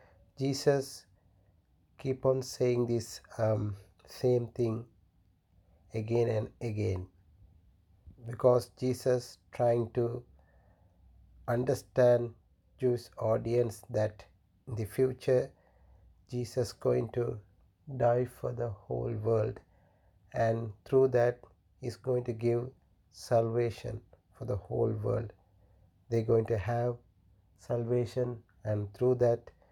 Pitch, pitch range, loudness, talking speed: 115 Hz, 95-120 Hz, -32 LUFS, 100 wpm